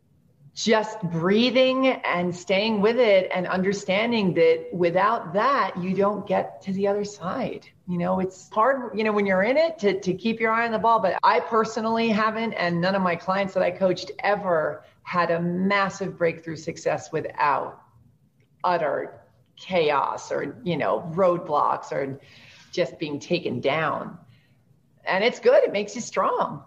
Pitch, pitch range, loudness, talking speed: 190 Hz, 175-220 Hz, -23 LUFS, 165 wpm